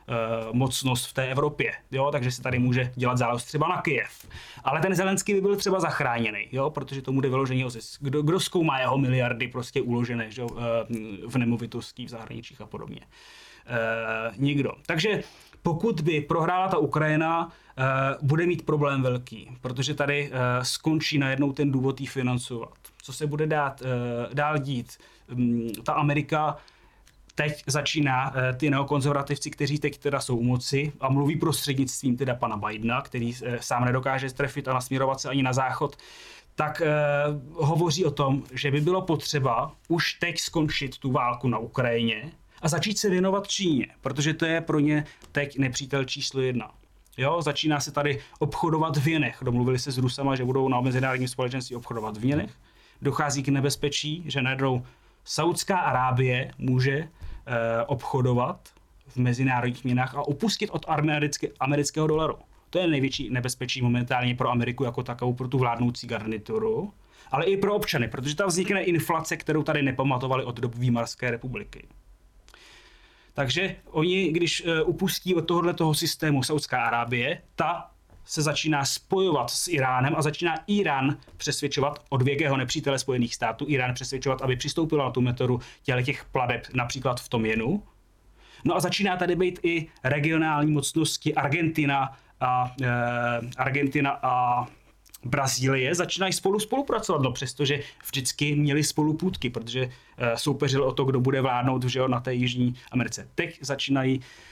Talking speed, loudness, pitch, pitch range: 155 wpm, -26 LUFS, 135 Hz, 125-155 Hz